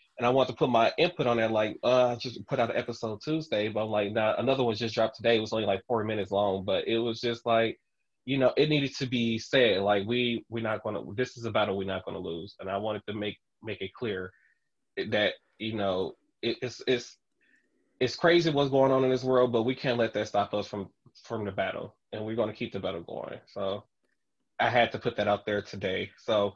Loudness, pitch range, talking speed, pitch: -29 LUFS, 105-125 Hz, 255 wpm, 110 Hz